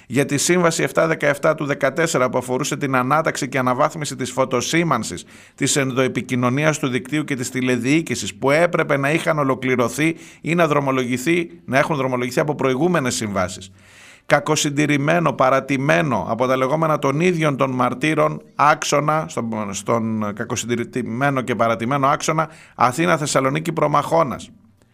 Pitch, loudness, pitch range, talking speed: 140 Hz, -19 LUFS, 125-155 Hz, 125 wpm